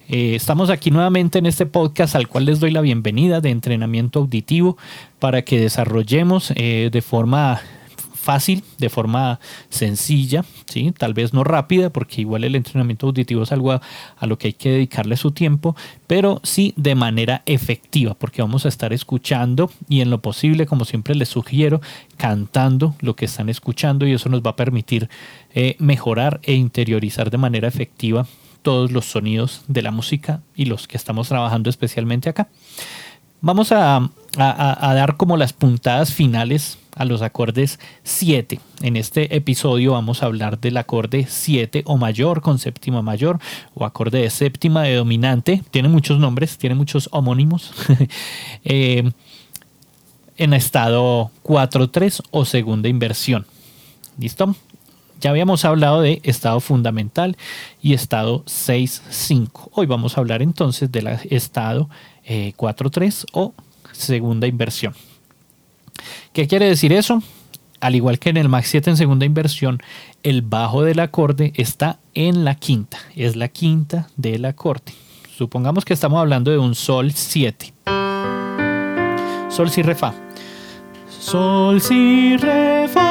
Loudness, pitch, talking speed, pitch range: -18 LUFS, 135 Hz, 150 wpm, 120-155 Hz